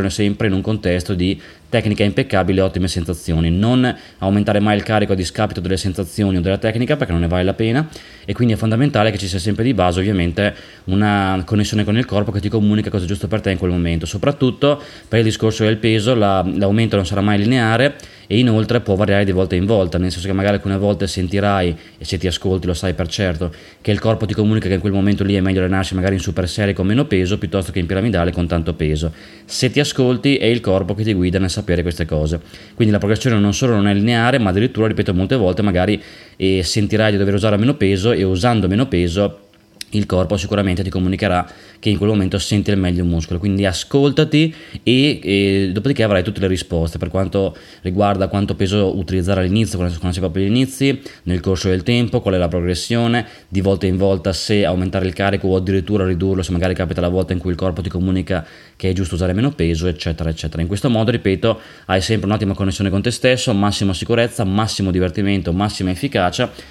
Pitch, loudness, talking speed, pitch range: 100 Hz, -17 LUFS, 220 wpm, 95-110 Hz